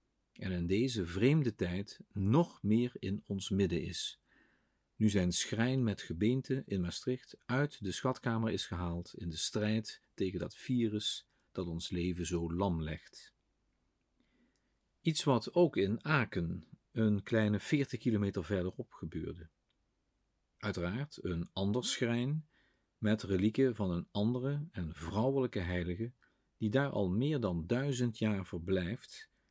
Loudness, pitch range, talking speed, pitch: -35 LUFS, 90-125 Hz, 135 wpm, 105 Hz